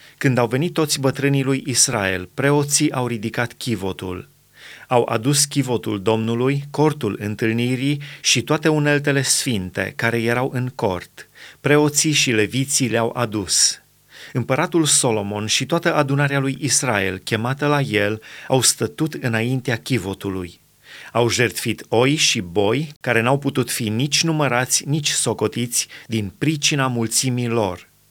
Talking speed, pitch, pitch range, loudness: 130 wpm, 125 Hz, 115-145 Hz, -19 LUFS